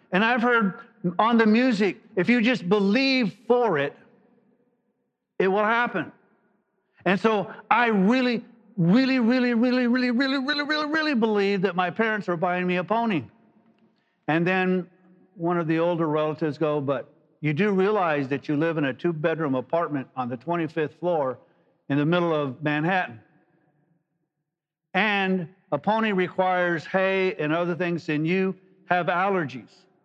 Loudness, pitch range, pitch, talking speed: -24 LUFS, 165-225 Hz, 185 Hz, 155 wpm